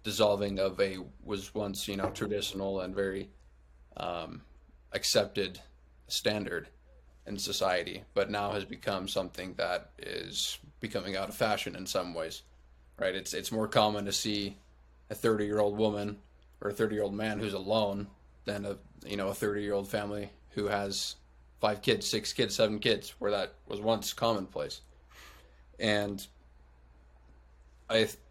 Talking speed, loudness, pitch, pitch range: 155 wpm, -33 LUFS, 100 Hz, 65-105 Hz